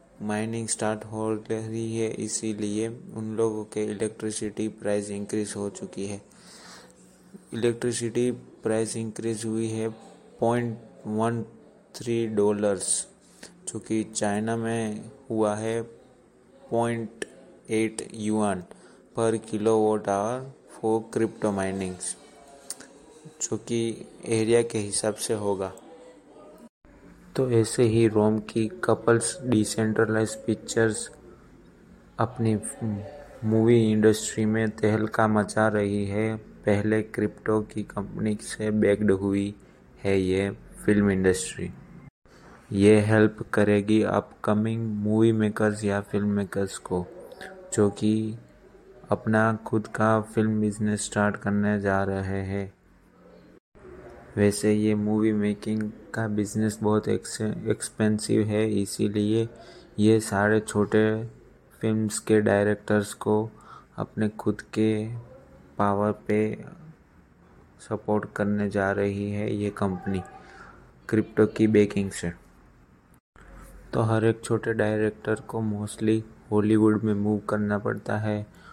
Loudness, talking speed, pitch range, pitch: -26 LUFS, 105 wpm, 105-110 Hz, 110 Hz